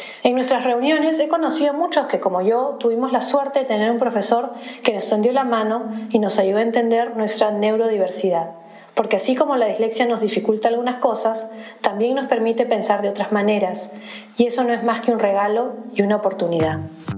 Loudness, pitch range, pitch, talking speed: -19 LUFS, 210-250 Hz, 225 Hz, 195 wpm